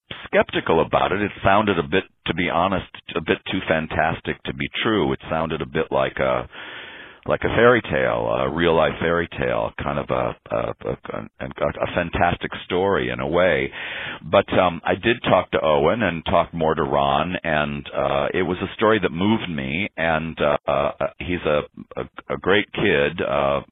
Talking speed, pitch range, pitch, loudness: 190 wpm, 70-85 Hz, 80 Hz, -21 LUFS